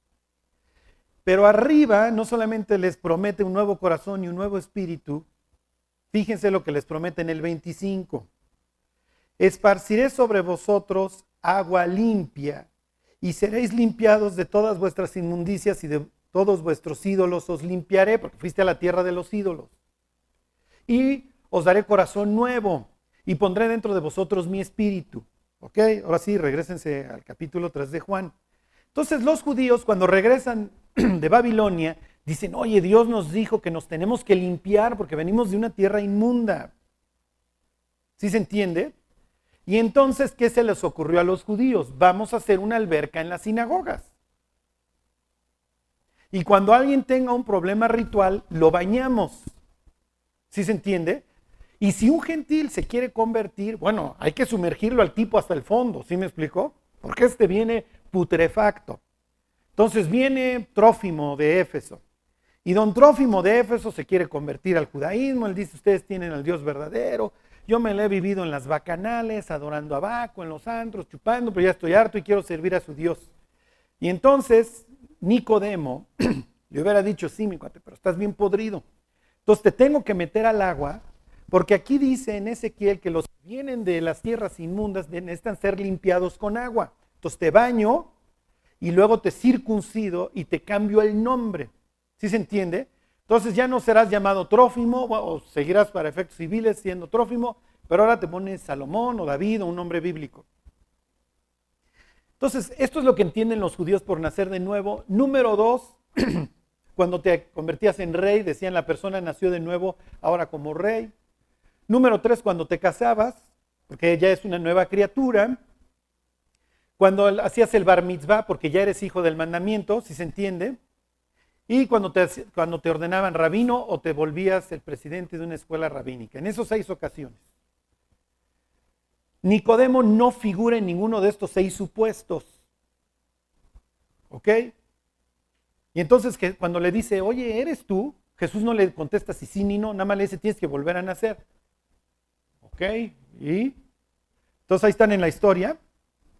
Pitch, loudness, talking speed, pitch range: 190 Hz, -23 LUFS, 160 wpm, 160-220 Hz